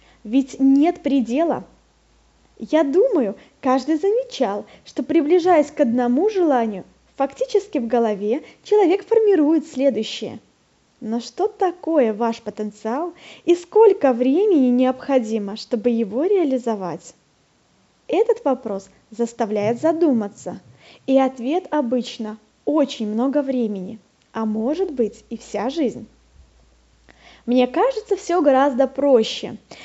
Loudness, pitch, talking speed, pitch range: -20 LUFS, 265 Hz, 105 wpm, 225-325 Hz